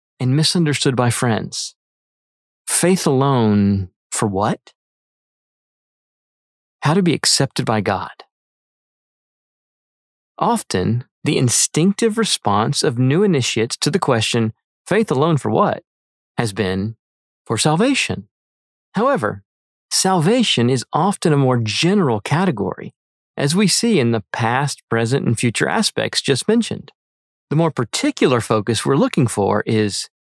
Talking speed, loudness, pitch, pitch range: 120 wpm, -17 LUFS, 125 Hz, 110-165 Hz